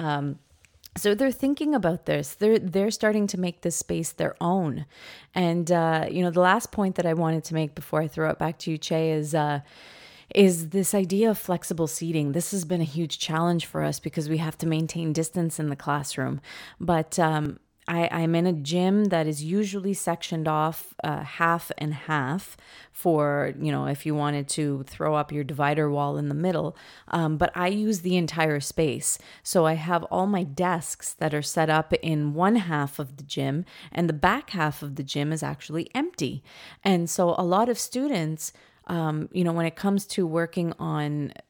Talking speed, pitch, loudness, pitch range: 200 wpm, 165 Hz, -26 LUFS, 155-180 Hz